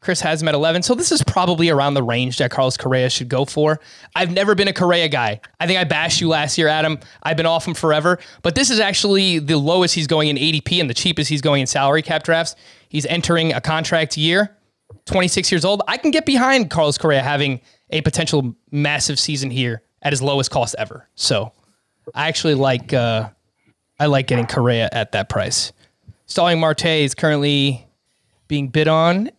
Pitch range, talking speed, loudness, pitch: 140-170 Hz, 205 wpm, -17 LUFS, 155 Hz